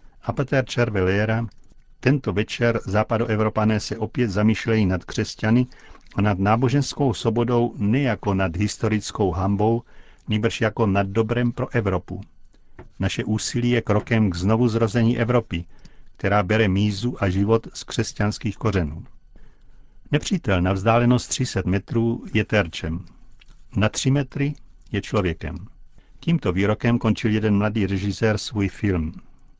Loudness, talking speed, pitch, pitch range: -22 LUFS, 120 wpm, 110 Hz, 100-120 Hz